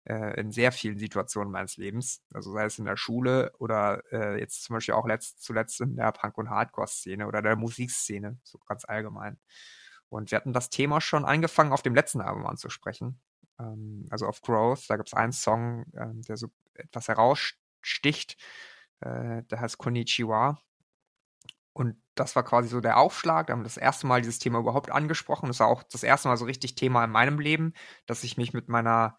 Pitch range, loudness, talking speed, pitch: 110-130 Hz, -28 LUFS, 195 wpm, 120 Hz